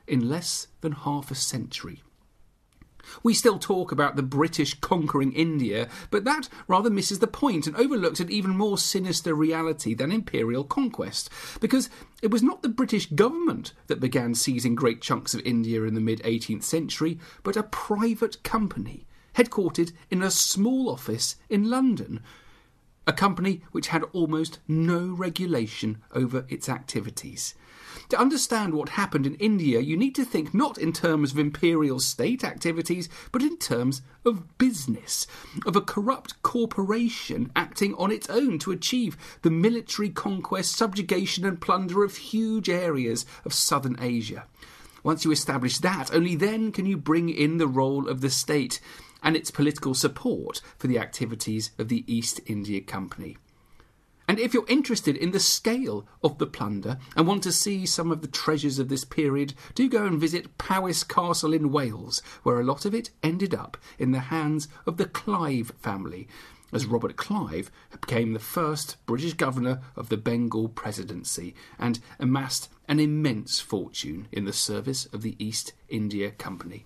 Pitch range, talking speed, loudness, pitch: 135-205 Hz, 165 wpm, -26 LUFS, 160 Hz